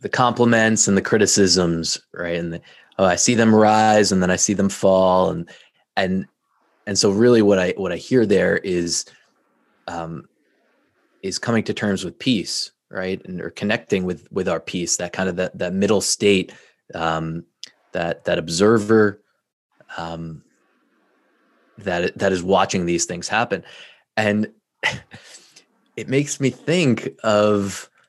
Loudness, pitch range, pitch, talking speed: -19 LUFS, 90-110 Hz, 100 Hz, 150 wpm